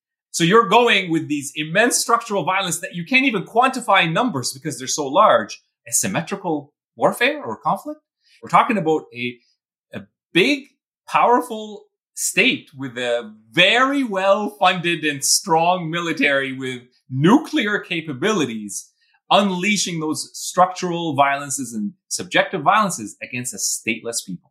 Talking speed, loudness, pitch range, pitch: 130 wpm, -19 LUFS, 145-230 Hz, 180 Hz